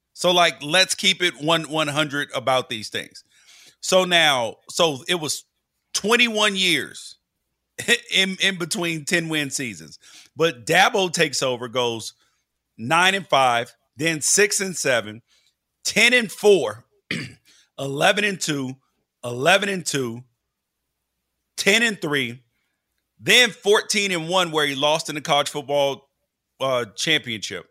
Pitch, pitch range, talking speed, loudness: 155 Hz, 130-185 Hz, 130 wpm, -20 LUFS